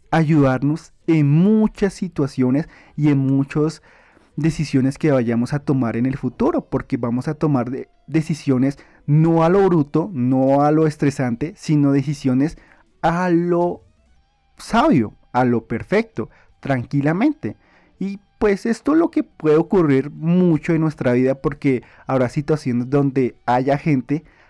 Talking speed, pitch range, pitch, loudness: 135 wpm, 130-165 Hz, 150 Hz, -19 LUFS